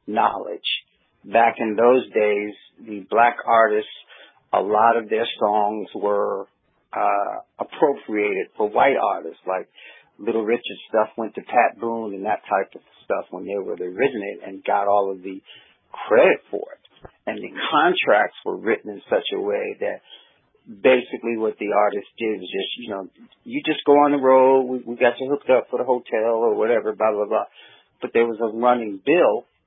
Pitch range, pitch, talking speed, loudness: 105-145 Hz, 115 Hz, 185 wpm, -21 LUFS